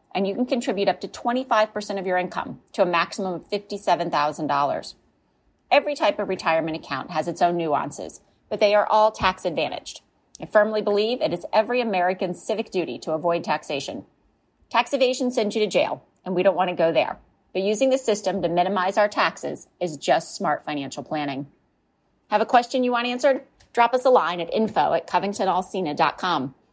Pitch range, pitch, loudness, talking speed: 175-225 Hz, 195 Hz, -23 LUFS, 180 wpm